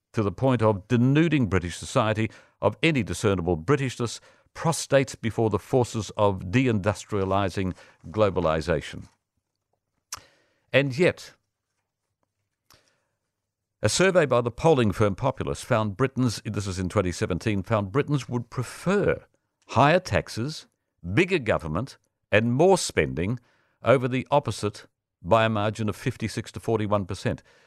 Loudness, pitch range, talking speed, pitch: -25 LUFS, 100-125 Hz, 115 wpm, 110 Hz